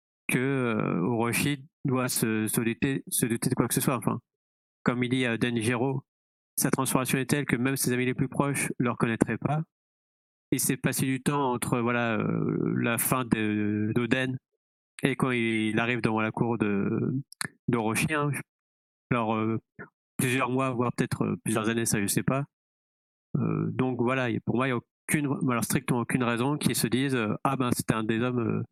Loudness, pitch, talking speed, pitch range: -28 LUFS, 125 Hz, 200 wpm, 110-135 Hz